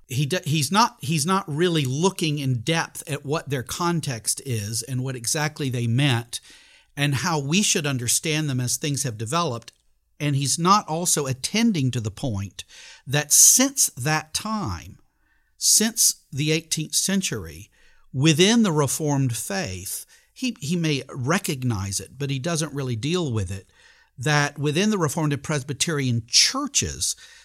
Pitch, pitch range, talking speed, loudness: 150 Hz, 130-170 Hz, 145 wpm, -22 LUFS